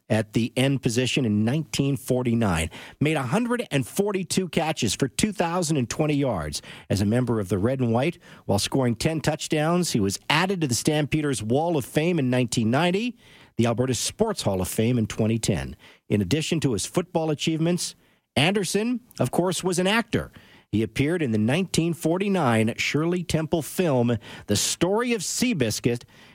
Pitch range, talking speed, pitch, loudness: 120-175 Hz, 155 wpm, 145 Hz, -24 LUFS